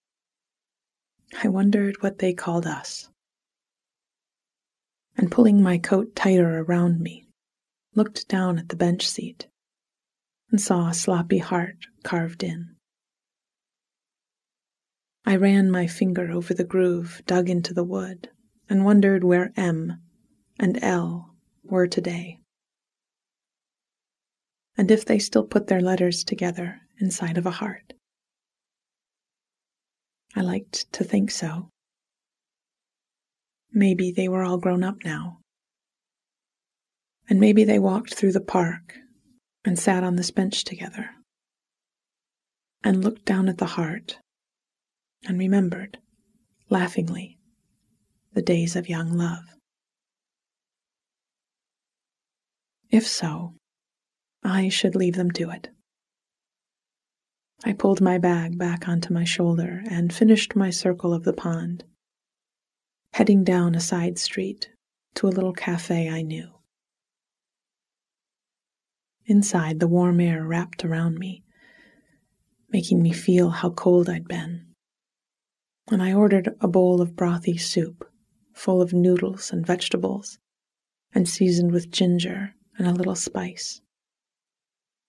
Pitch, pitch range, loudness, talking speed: 185 Hz, 175-200 Hz, -23 LUFS, 115 wpm